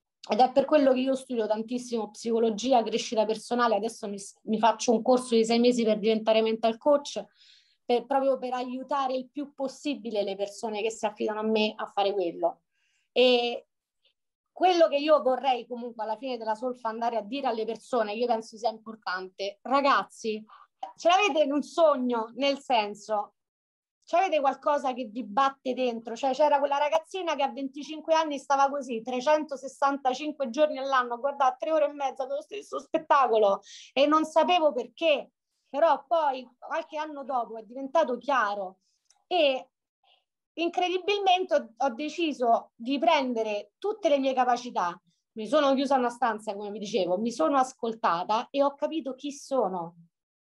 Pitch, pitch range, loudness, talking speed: 255 Hz, 225-290 Hz, -27 LUFS, 160 wpm